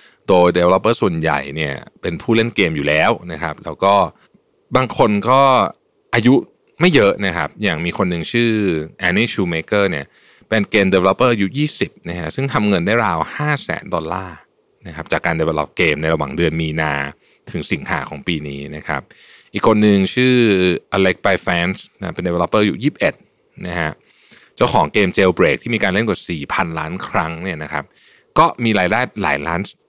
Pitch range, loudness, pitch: 80-115 Hz, -17 LUFS, 95 Hz